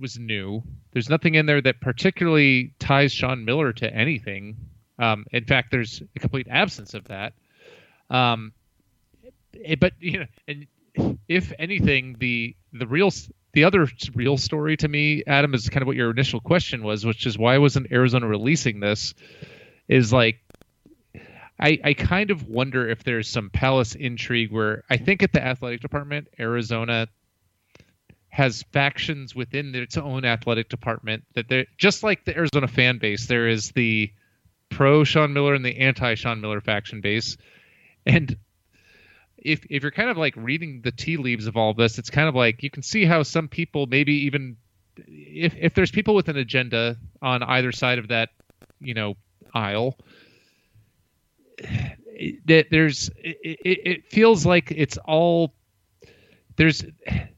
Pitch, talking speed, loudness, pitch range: 125 Hz, 160 wpm, -22 LUFS, 115-150 Hz